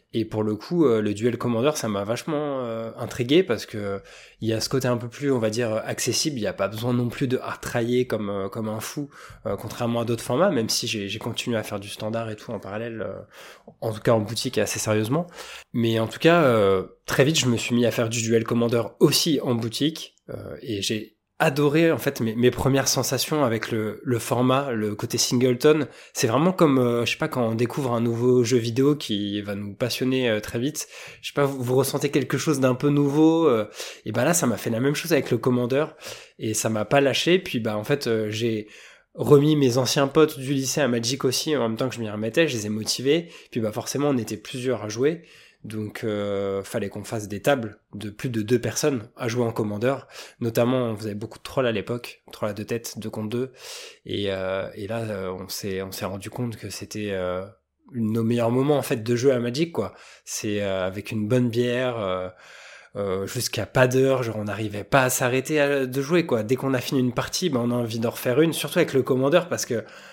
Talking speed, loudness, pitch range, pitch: 240 wpm, -24 LUFS, 110-135 Hz, 120 Hz